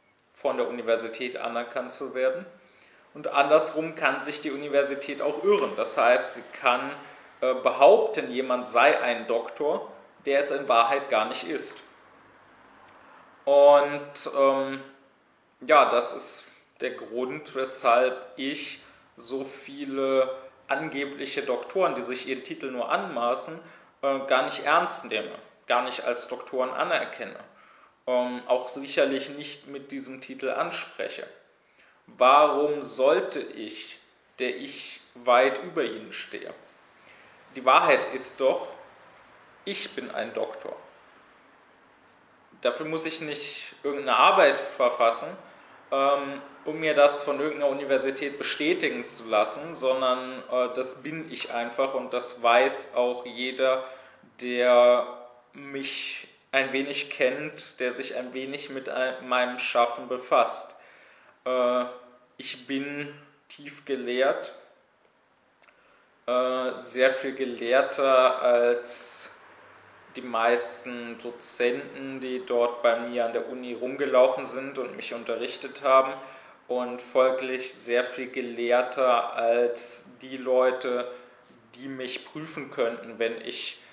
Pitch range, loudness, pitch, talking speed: 125-140 Hz, -26 LUFS, 130 Hz, 115 wpm